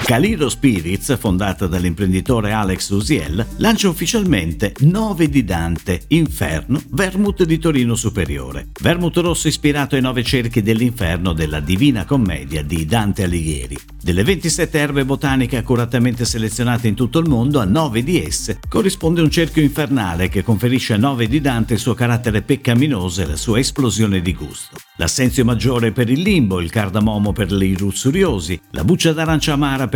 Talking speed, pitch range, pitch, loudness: 155 wpm, 95-145 Hz, 120 Hz, -17 LUFS